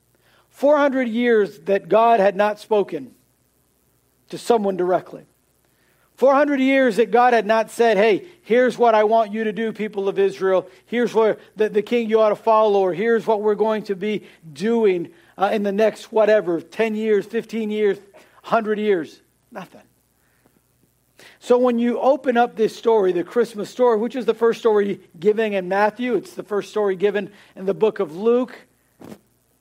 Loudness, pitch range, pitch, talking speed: -19 LUFS, 200-230 Hz, 215 Hz, 170 wpm